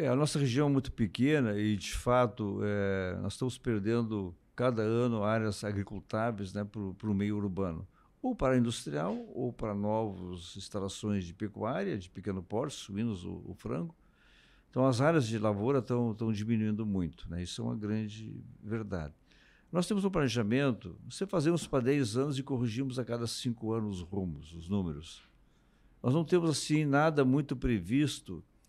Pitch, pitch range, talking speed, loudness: 110 Hz, 100-130 Hz, 165 wpm, -33 LUFS